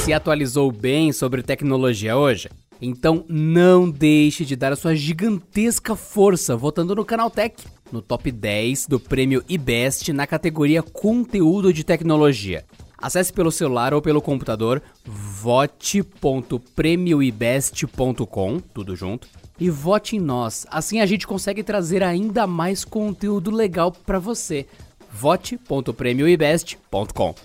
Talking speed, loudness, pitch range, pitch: 120 wpm, -20 LUFS, 130-185 Hz, 155 Hz